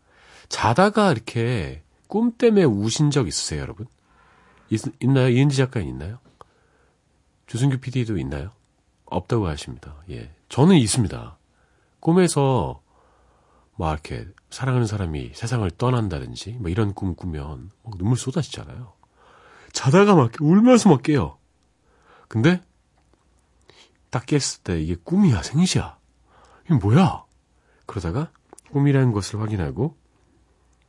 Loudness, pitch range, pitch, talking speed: -21 LUFS, 90-140 Hz, 120 Hz, 260 characters per minute